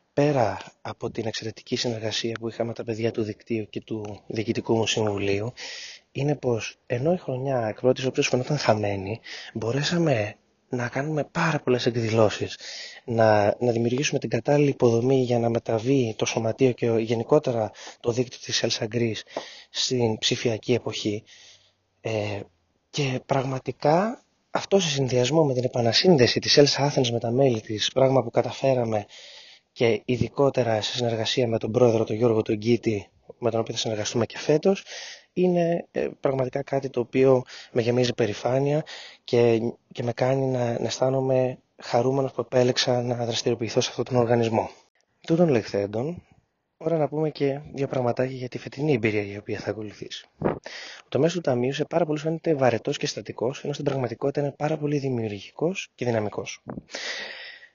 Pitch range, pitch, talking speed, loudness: 115-140 Hz, 125 Hz, 155 wpm, -25 LUFS